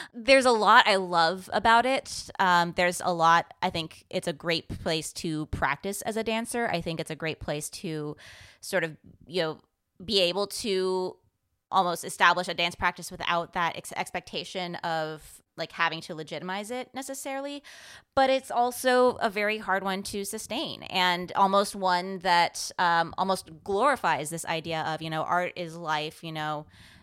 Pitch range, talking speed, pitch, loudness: 165-200 Hz, 175 wpm, 180 Hz, -27 LUFS